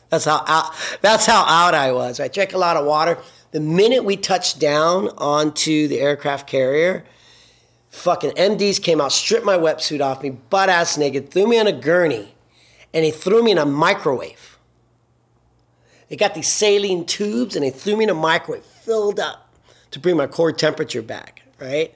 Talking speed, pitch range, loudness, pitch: 185 wpm, 150-205 Hz, -18 LUFS, 170 Hz